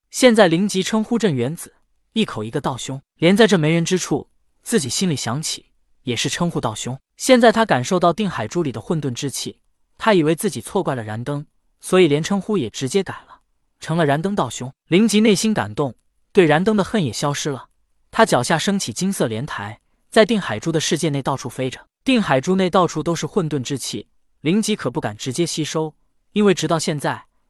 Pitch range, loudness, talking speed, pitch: 140-195 Hz, -19 LUFS, 300 characters per minute, 165 Hz